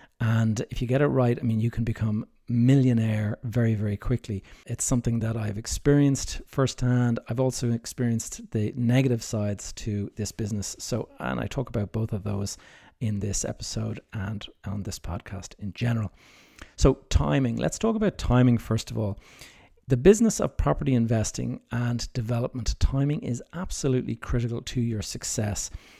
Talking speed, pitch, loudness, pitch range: 165 wpm, 115 Hz, -27 LUFS, 105-125 Hz